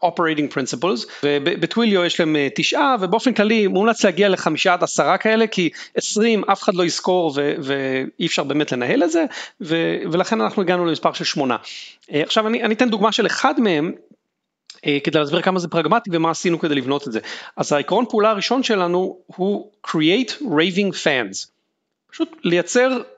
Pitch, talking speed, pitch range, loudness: 180 Hz, 165 wpm, 165-220 Hz, -19 LUFS